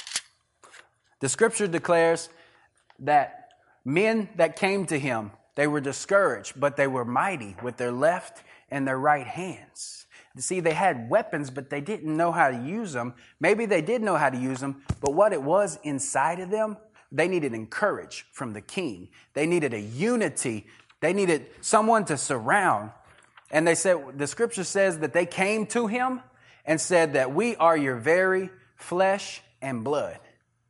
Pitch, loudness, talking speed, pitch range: 165 Hz, -25 LUFS, 170 wpm, 140-195 Hz